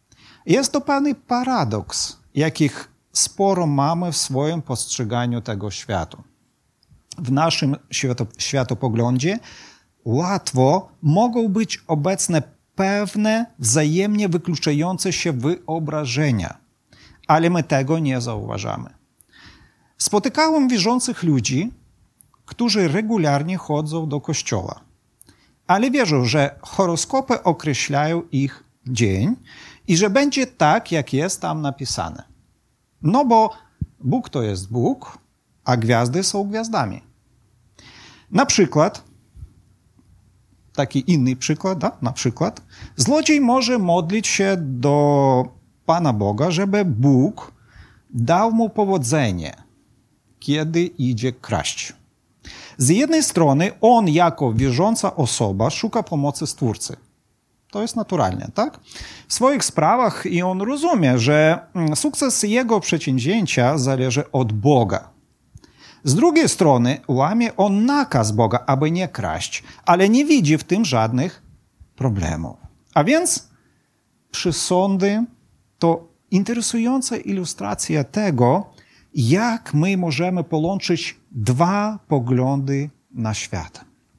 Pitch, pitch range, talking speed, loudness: 155 Hz, 125-195 Hz, 100 wpm, -19 LUFS